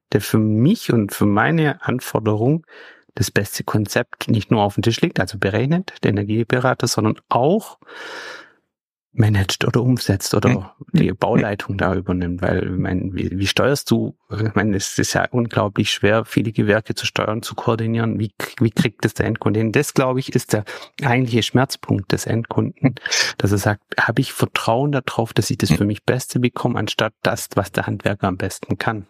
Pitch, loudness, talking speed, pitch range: 115 Hz, -19 LUFS, 180 wpm, 105-125 Hz